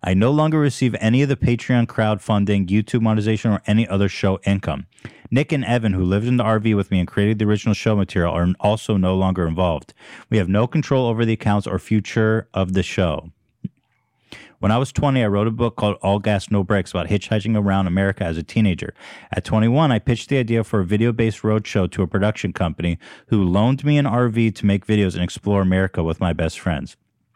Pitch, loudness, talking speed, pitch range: 105 Hz, -20 LUFS, 215 wpm, 95-115 Hz